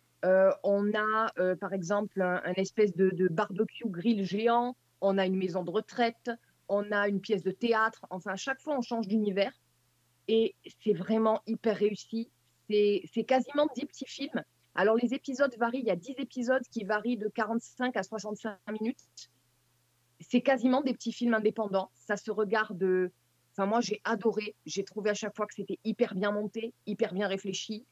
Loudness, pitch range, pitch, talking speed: -31 LUFS, 190-230 Hz, 215 Hz, 185 wpm